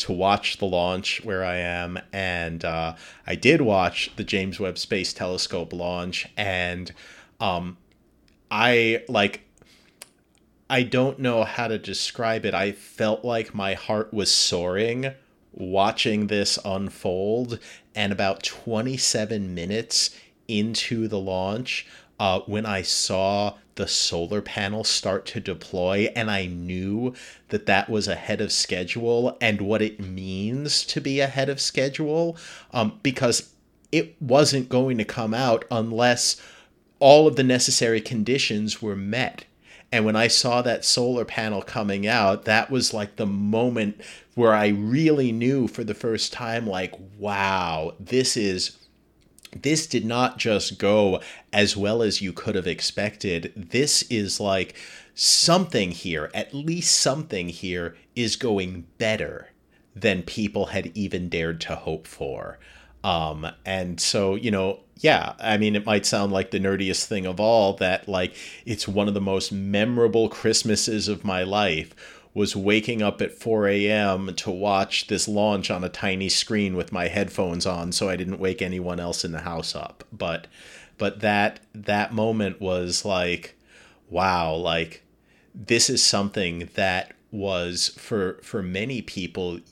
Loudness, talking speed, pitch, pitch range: -23 LUFS, 150 wpm, 105 Hz, 95-115 Hz